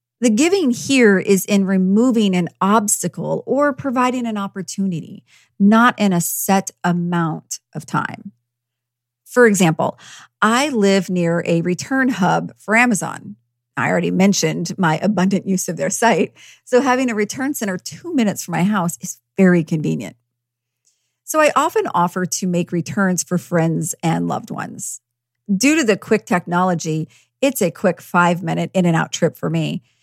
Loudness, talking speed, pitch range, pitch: -18 LUFS, 160 wpm, 165-215 Hz, 185 Hz